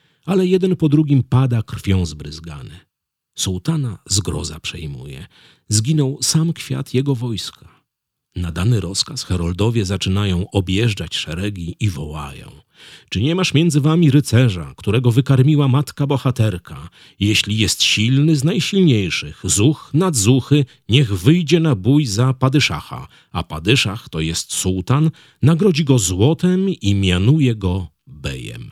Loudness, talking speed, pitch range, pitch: -17 LUFS, 125 wpm, 95-145 Hz, 120 Hz